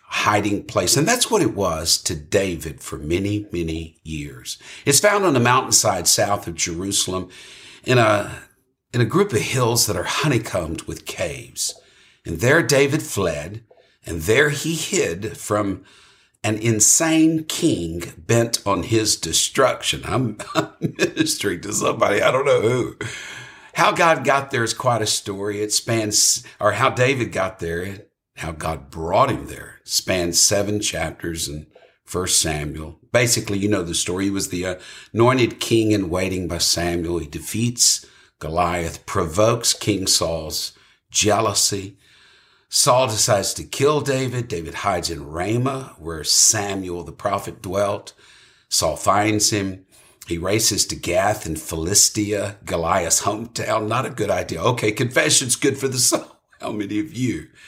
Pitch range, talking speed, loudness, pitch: 85-120 Hz, 150 wpm, -19 LUFS, 105 Hz